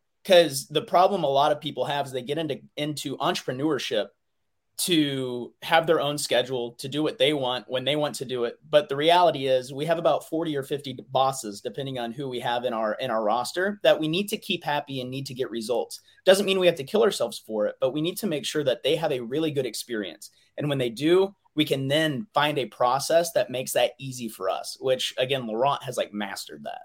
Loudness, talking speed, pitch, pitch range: -25 LUFS, 240 wpm, 145 Hz, 130-175 Hz